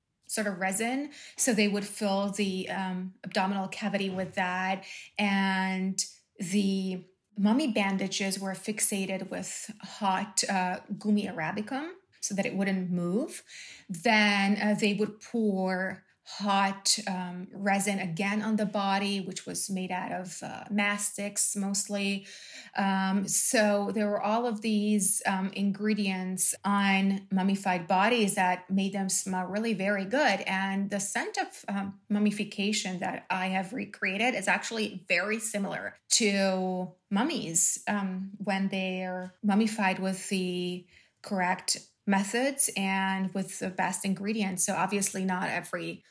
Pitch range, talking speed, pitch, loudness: 190-210 Hz, 135 wpm, 195 Hz, -29 LUFS